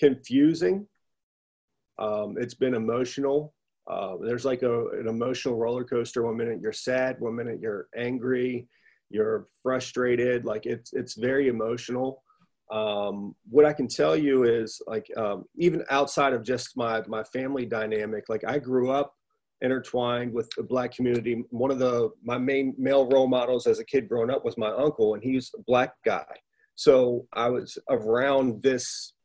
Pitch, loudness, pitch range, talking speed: 125 Hz, -27 LUFS, 115-135 Hz, 165 wpm